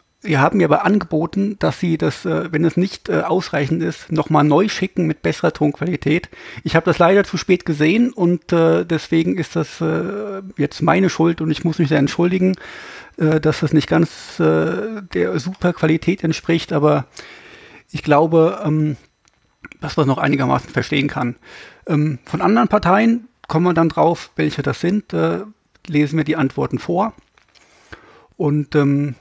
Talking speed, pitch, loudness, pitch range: 150 wpm, 165 Hz, -18 LUFS, 150-185 Hz